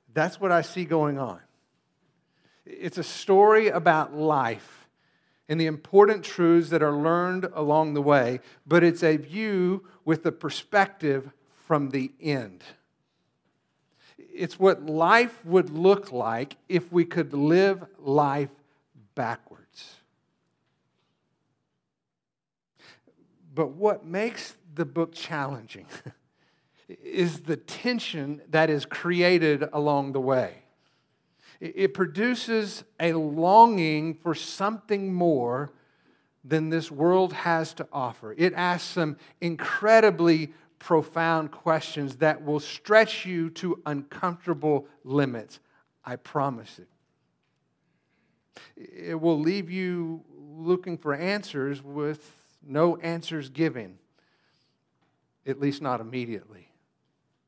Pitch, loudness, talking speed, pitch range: 160 Hz, -25 LUFS, 105 wpm, 145-180 Hz